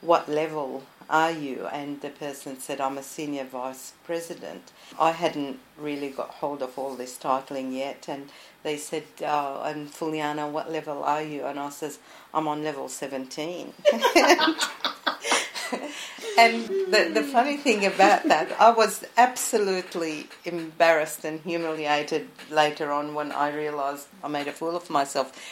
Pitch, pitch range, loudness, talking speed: 150 Hz, 145-170 Hz, -25 LUFS, 150 wpm